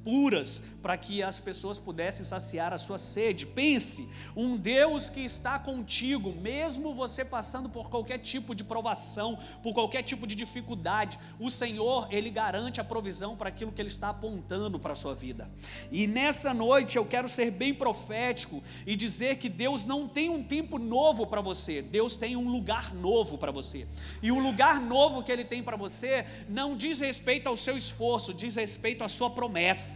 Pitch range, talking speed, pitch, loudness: 220-265 Hz, 180 wpm, 240 Hz, -30 LUFS